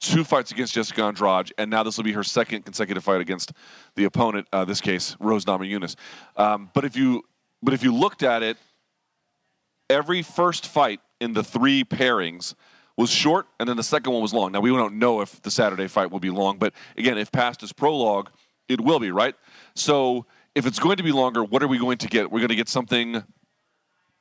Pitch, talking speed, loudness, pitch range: 115 Hz, 220 wpm, -23 LUFS, 105-135 Hz